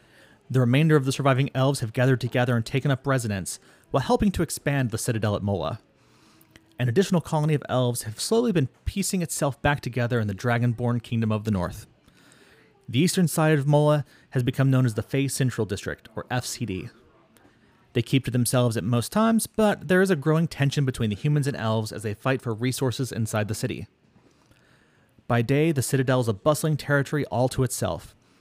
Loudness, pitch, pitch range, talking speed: -24 LUFS, 130 Hz, 115-145 Hz, 195 wpm